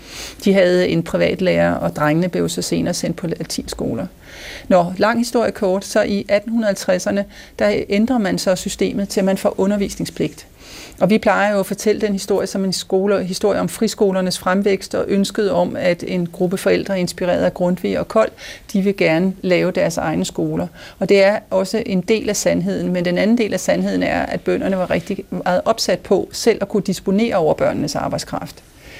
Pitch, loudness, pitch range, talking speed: 195 Hz, -18 LUFS, 185-205 Hz, 190 wpm